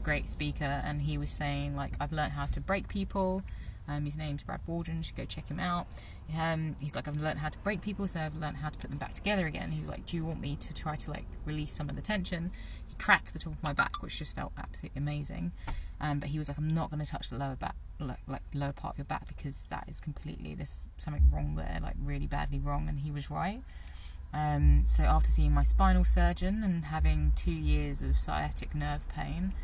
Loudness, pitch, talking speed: -33 LUFS, 145 Hz, 240 wpm